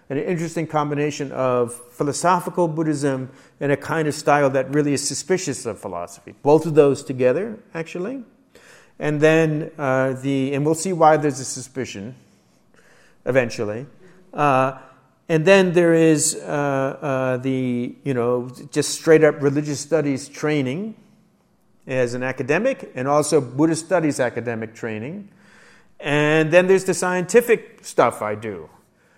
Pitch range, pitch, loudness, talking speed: 130-170 Hz, 145 Hz, -20 LUFS, 140 wpm